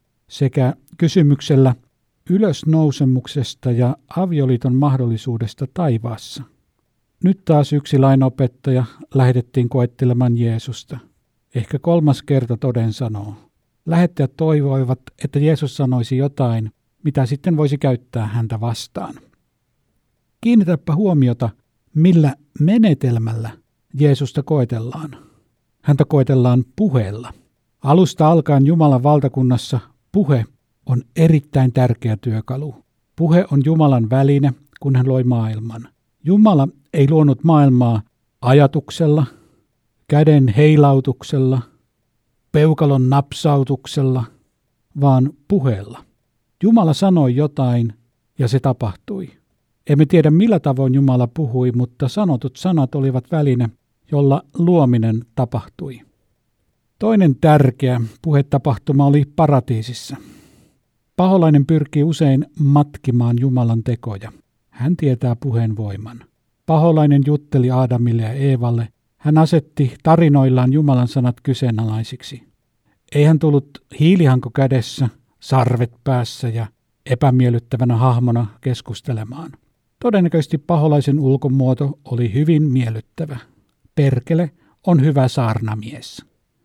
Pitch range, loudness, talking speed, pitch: 120-150 Hz, -16 LUFS, 95 wpm, 135 Hz